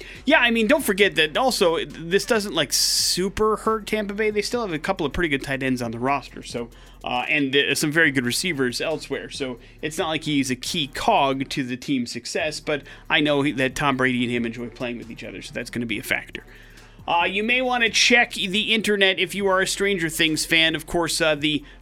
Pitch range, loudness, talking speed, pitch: 135-205 Hz, -21 LUFS, 240 wpm, 155 Hz